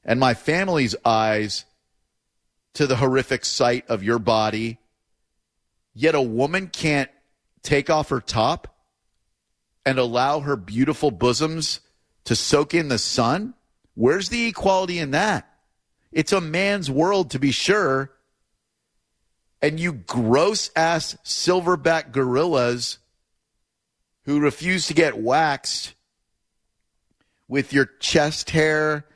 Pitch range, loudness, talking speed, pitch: 110-160 Hz, -21 LUFS, 115 wpm, 135 Hz